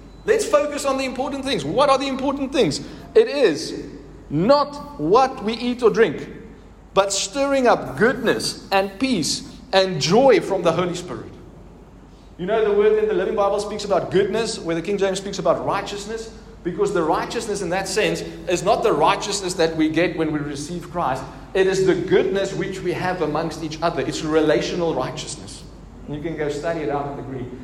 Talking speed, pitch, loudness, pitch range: 190 wpm, 195 Hz, -21 LUFS, 165-225 Hz